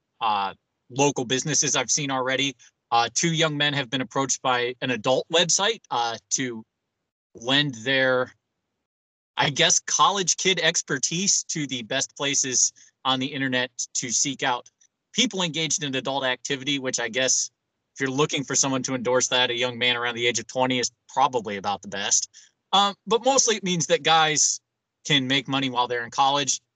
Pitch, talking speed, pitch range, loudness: 130 Hz, 175 wpm, 125-150 Hz, -23 LUFS